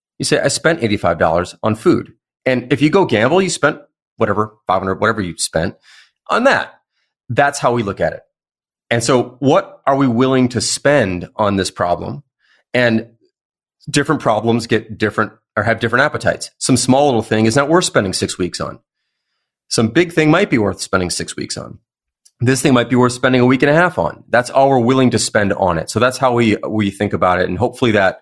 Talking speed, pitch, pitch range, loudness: 210 wpm, 120 Hz, 105-135 Hz, -15 LUFS